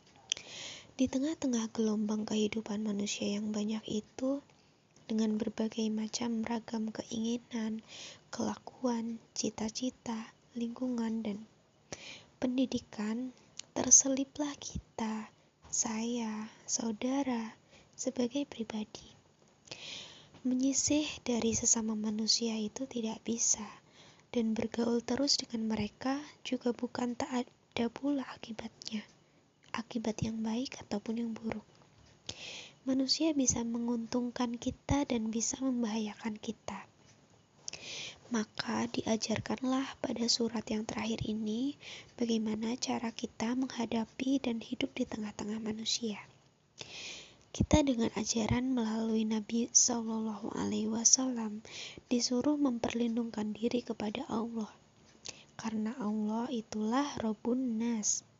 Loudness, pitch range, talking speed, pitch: -34 LUFS, 220-250 Hz, 90 wpm, 230 Hz